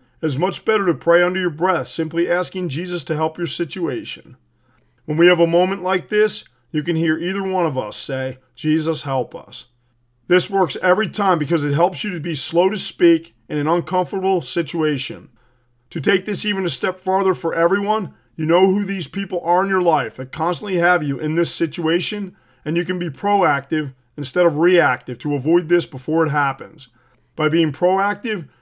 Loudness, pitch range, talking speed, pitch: -19 LUFS, 150-185 Hz, 195 wpm, 170 Hz